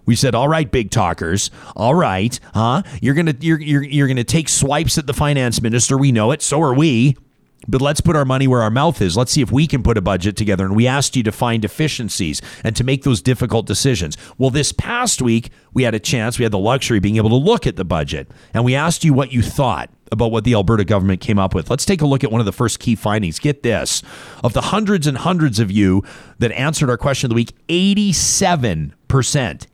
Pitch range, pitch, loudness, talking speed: 110-145 Hz, 125 Hz, -16 LUFS, 245 wpm